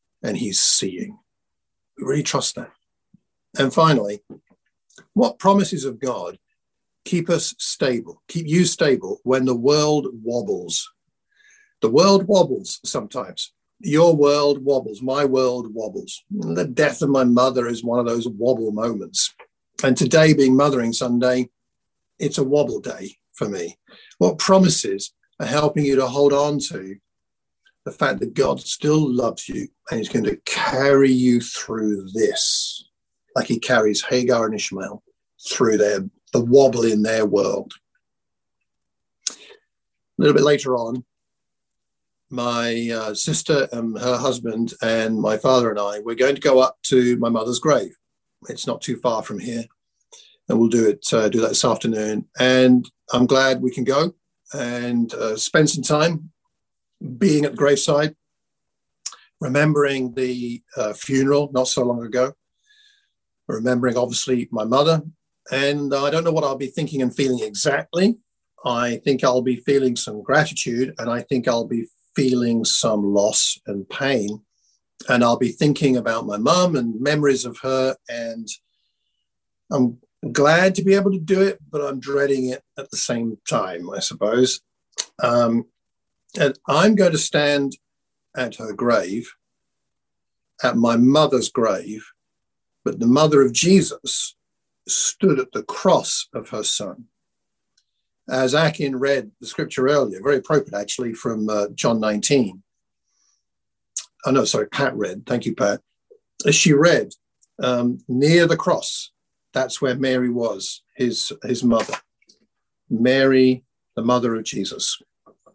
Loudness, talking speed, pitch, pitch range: -20 LUFS, 145 wpm, 130 Hz, 120-145 Hz